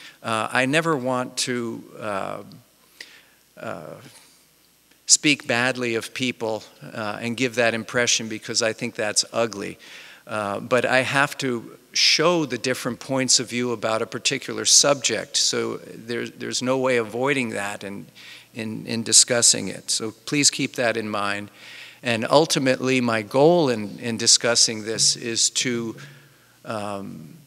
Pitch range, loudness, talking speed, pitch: 110-130 Hz, -21 LUFS, 140 wpm, 120 Hz